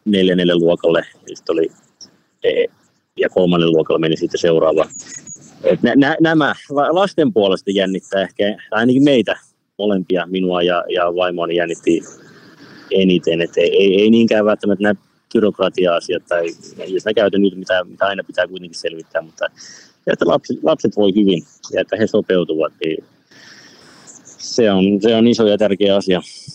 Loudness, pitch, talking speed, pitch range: -16 LUFS, 95 Hz, 140 wpm, 90-110 Hz